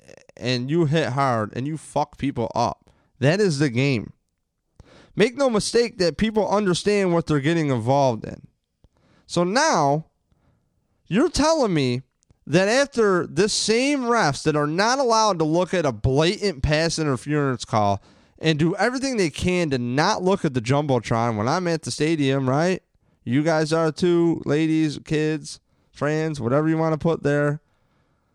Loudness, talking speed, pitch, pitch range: -22 LUFS, 160 wpm, 155 Hz, 140-185 Hz